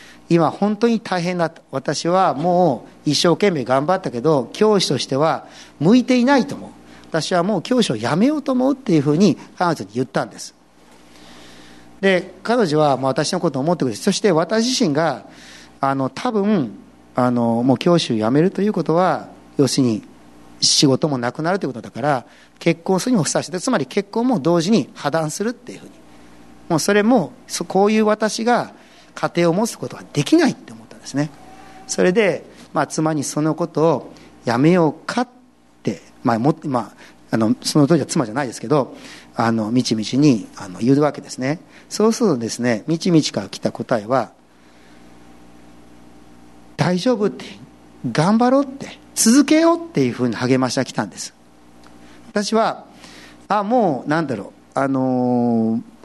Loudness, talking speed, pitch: -19 LUFS, 335 characters per minute, 155 Hz